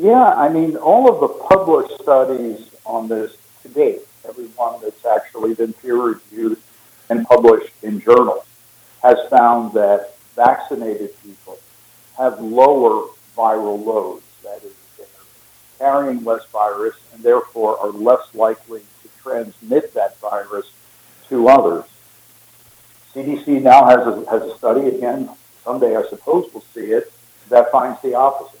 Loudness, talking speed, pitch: -16 LUFS, 135 wpm, 130 Hz